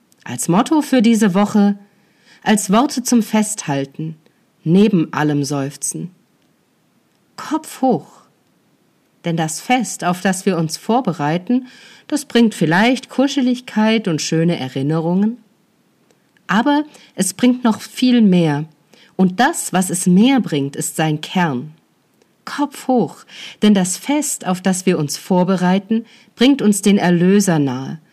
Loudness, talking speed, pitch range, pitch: -17 LUFS, 125 wpm, 165-235 Hz, 200 Hz